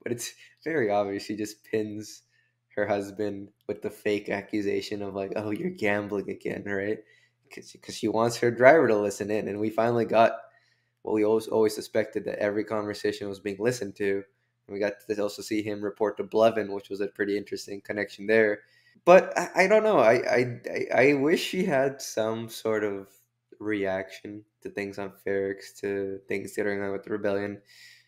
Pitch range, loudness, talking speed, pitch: 100-110 Hz, -27 LUFS, 190 wpm, 105 Hz